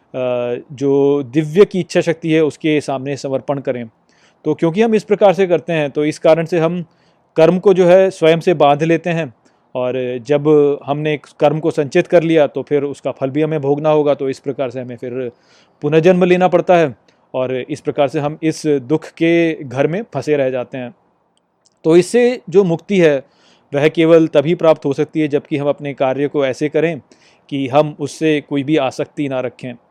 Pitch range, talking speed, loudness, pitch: 140-165 Hz, 200 wpm, -15 LUFS, 150 Hz